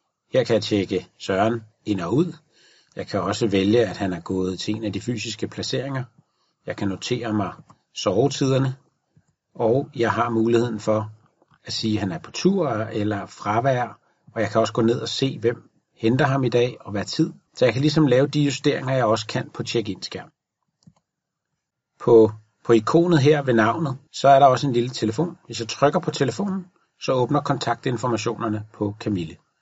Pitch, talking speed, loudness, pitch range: 120 Hz, 190 wpm, -22 LUFS, 110-140 Hz